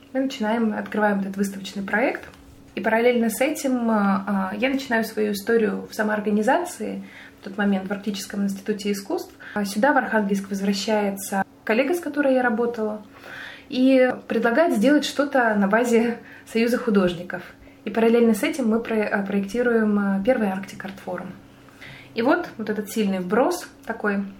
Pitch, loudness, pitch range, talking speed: 220 Hz, -22 LUFS, 205-250 Hz, 135 wpm